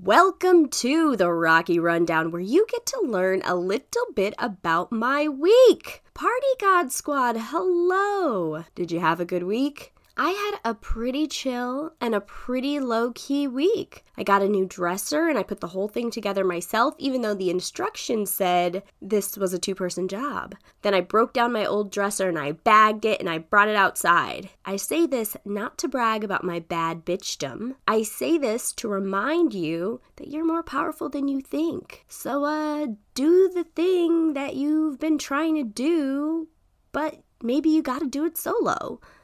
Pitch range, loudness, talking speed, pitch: 195-310 Hz, -24 LUFS, 175 wpm, 245 Hz